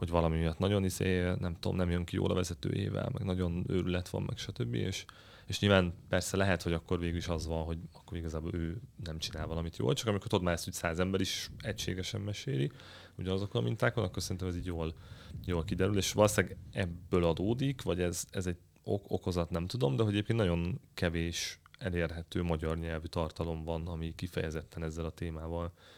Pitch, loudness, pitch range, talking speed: 90 Hz, -34 LUFS, 85-100 Hz, 195 wpm